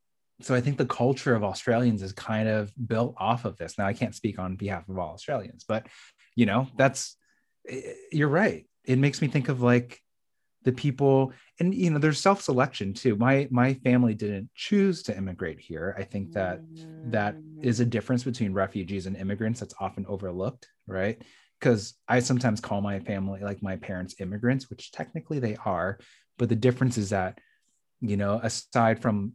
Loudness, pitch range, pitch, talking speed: -27 LUFS, 100-130 Hz, 115 Hz, 185 wpm